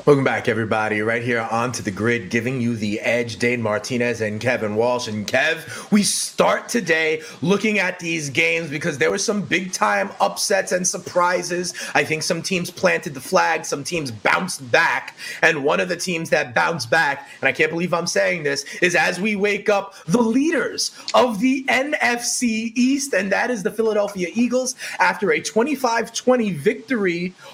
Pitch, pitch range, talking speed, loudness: 180 Hz, 130-215 Hz, 185 wpm, -20 LUFS